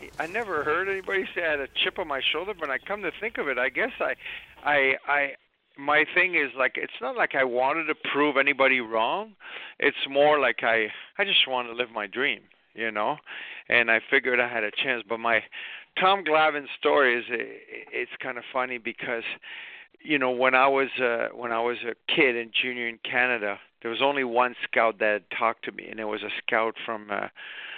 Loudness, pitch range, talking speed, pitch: -25 LUFS, 115-150 Hz, 220 wpm, 130 Hz